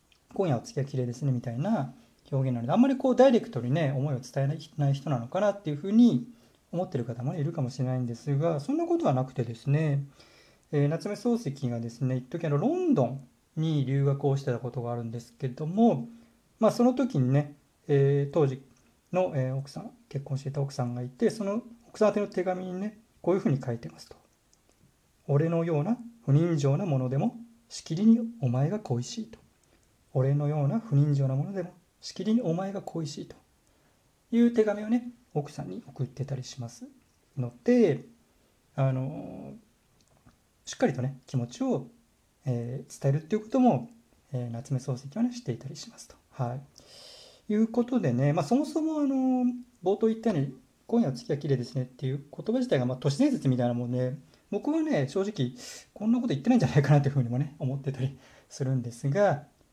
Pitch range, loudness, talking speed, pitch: 130-210 Hz, -28 LUFS, 385 characters per minute, 145 Hz